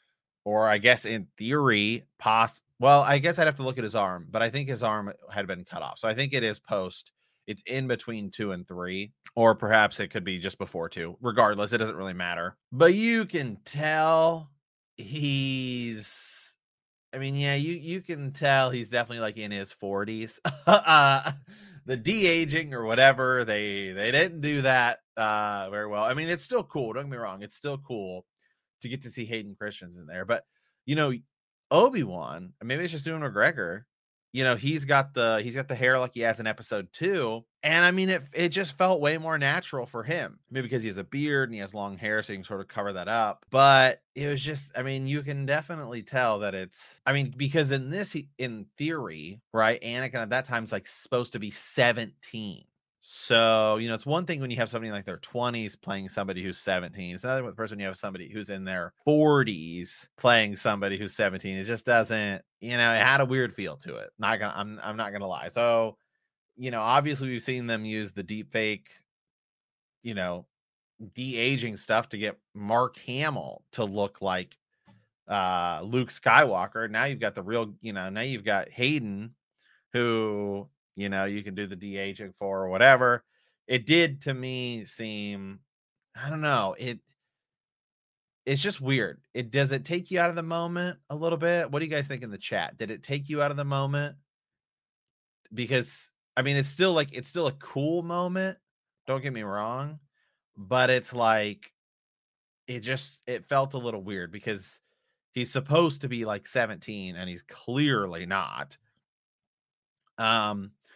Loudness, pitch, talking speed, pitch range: -27 LUFS, 120 Hz, 195 wpm, 105-140 Hz